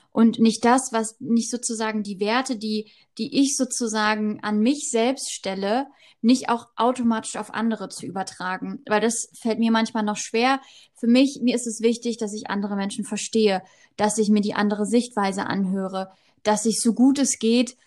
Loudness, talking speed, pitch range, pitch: -23 LUFS, 180 wpm, 210-240 Hz, 225 Hz